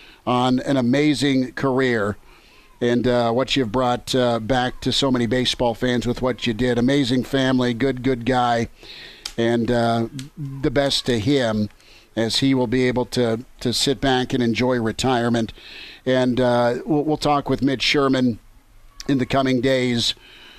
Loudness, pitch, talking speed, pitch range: -20 LUFS, 125 Hz, 150 wpm, 120-130 Hz